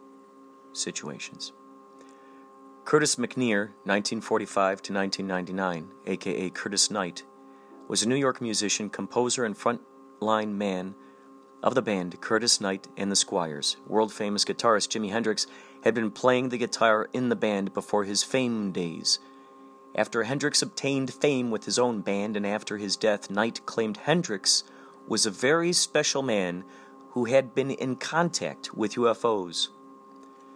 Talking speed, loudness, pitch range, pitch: 140 wpm, -27 LUFS, 95-135 Hz, 110 Hz